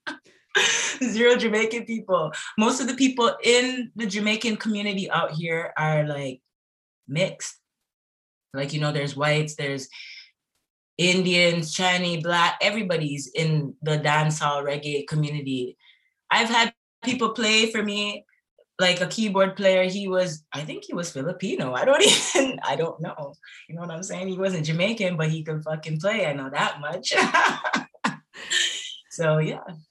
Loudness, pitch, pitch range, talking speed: -23 LUFS, 180 Hz, 155-220 Hz, 145 wpm